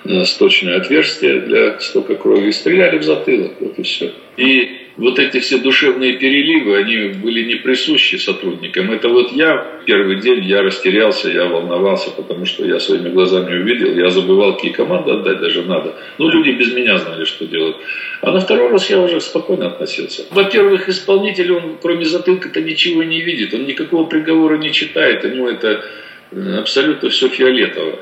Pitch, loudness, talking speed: 190 Hz, -14 LUFS, 170 wpm